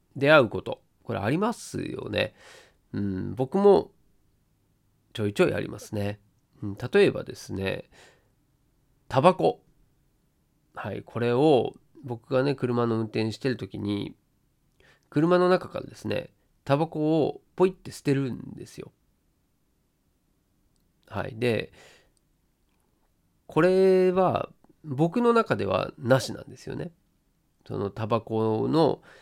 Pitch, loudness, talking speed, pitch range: 125 Hz, -26 LUFS, 210 characters per minute, 105-155 Hz